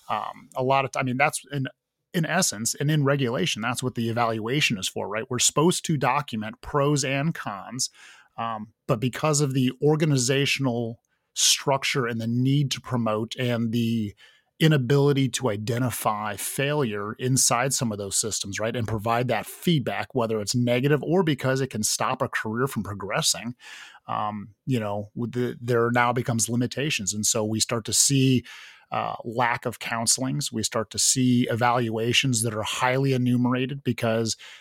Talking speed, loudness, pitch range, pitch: 170 wpm, -24 LUFS, 115-135 Hz, 125 Hz